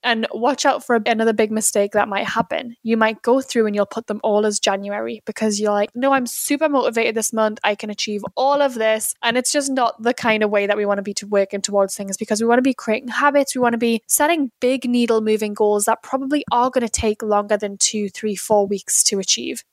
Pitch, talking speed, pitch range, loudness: 220 Hz, 240 wpm, 210-245 Hz, -19 LUFS